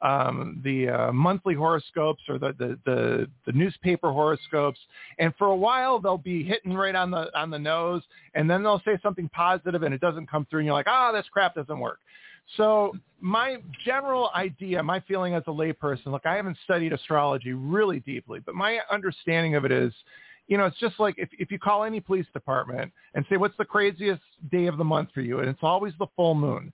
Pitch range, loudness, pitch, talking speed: 150-205 Hz, -26 LUFS, 175 Hz, 215 wpm